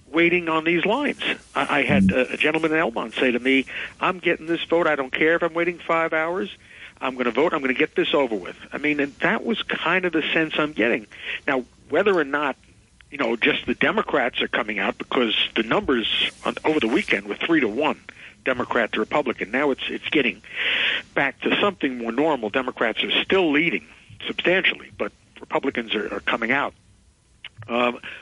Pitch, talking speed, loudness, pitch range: 160 Hz, 200 wpm, -22 LUFS, 140-175 Hz